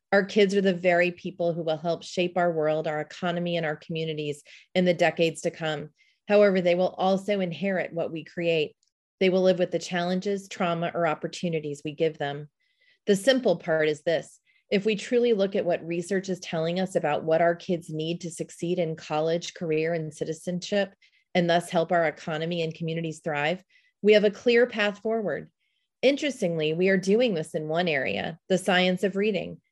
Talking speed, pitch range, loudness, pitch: 190 wpm, 160-195 Hz, -26 LUFS, 175 Hz